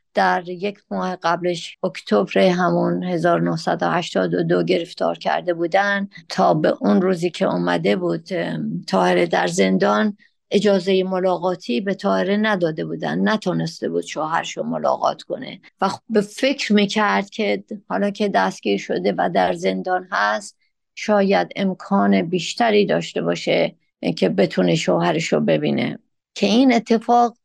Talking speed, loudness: 130 wpm, -20 LUFS